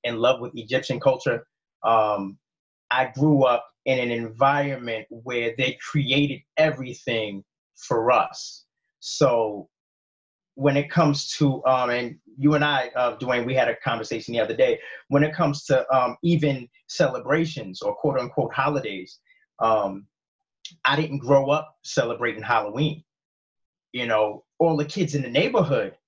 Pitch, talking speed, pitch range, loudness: 135 Hz, 145 wpm, 120-150 Hz, -23 LUFS